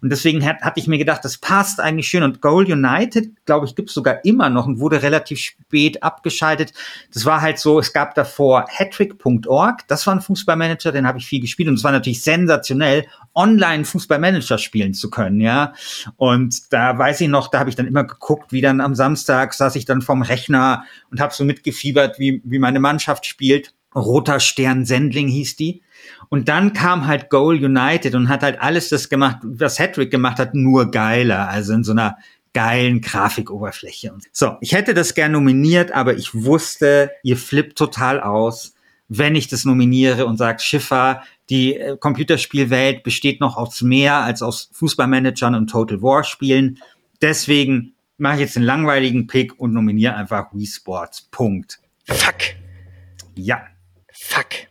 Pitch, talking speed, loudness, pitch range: 135 Hz, 175 wpm, -17 LUFS, 125-150 Hz